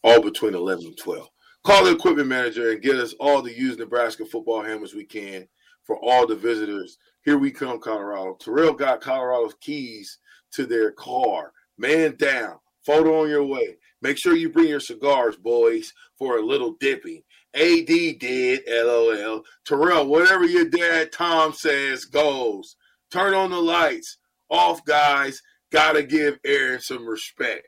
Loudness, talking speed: -21 LUFS, 160 wpm